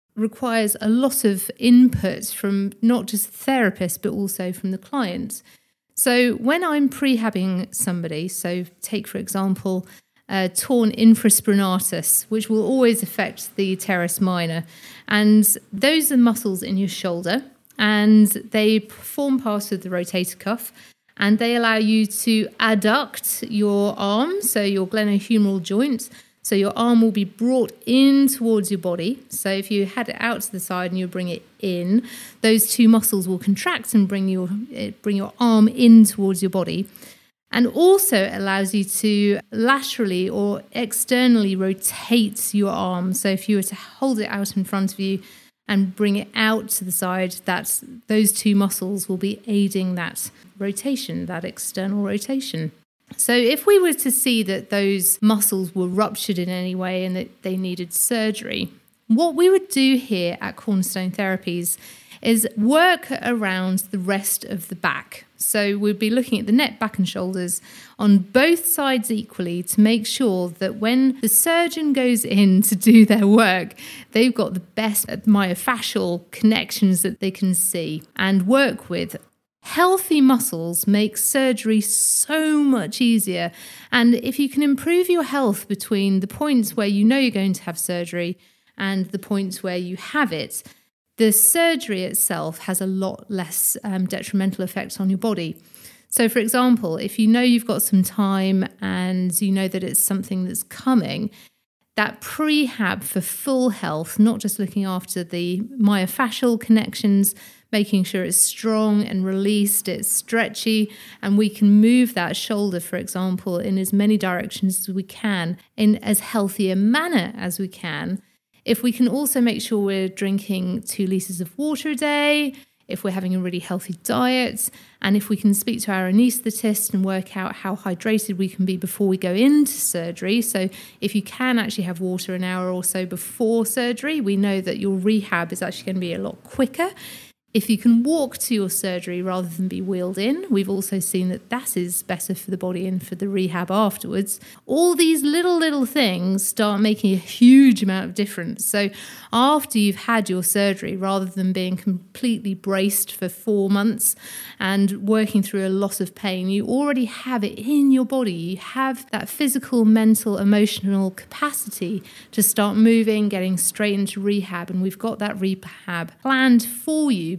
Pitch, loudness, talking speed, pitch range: 205 Hz, -20 LUFS, 170 wpm, 190-235 Hz